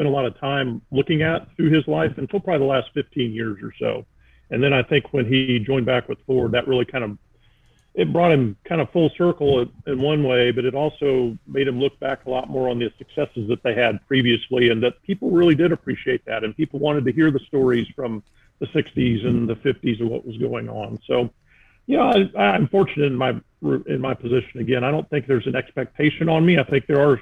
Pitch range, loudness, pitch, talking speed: 120-150 Hz, -21 LUFS, 130 Hz, 235 wpm